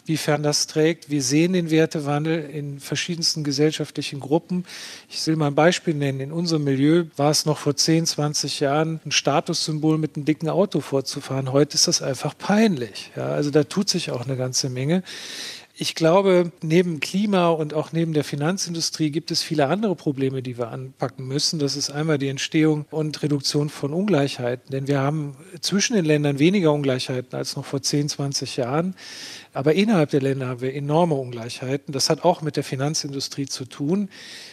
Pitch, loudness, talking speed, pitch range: 150 Hz, -22 LUFS, 185 wpm, 140-165 Hz